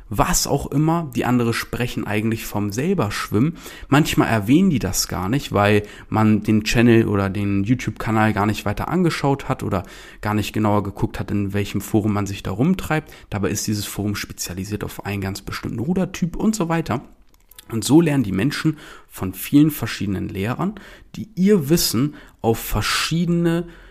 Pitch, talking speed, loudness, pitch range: 110 Hz, 170 wpm, -21 LUFS, 105-150 Hz